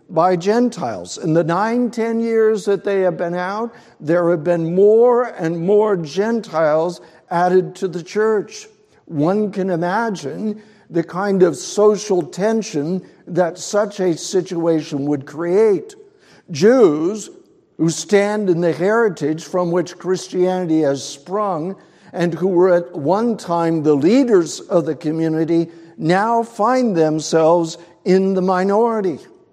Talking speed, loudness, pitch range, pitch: 130 wpm, -18 LUFS, 170-215 Hz, 185 Hz